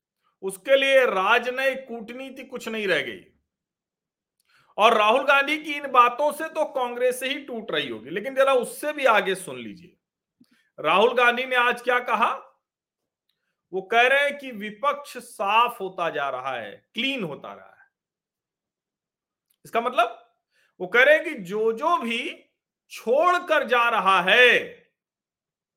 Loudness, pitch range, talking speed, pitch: -22 LUFS, 230-285 Hz, 150 wpm, 250 Hz